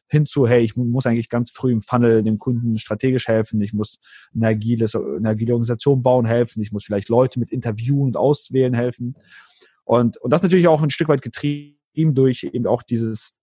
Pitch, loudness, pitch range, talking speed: 120 Hz, -19 LUFS, 115-130 Hz, 195 wpm